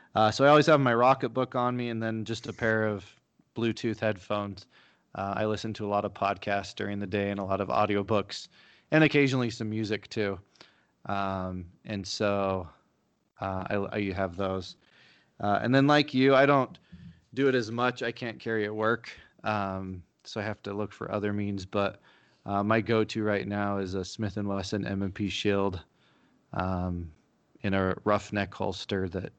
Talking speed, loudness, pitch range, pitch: 190 wpm, -29 LUFS, 100-115 Hz, 105 Hz